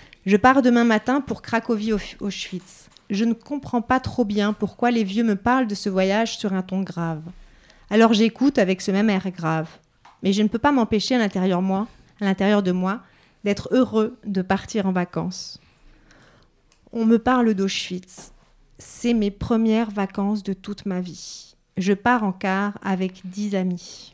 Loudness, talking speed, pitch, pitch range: -22 LUFS, 175 wpm, 205 Hz, 190-230 Hz